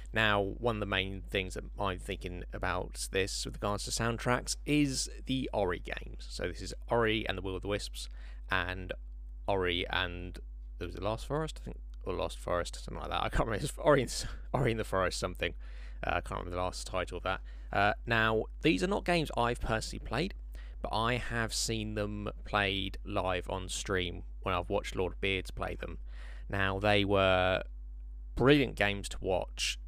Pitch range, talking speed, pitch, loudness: 85-110 Hz, 195 wpm, 95 Hz, -33 LUFS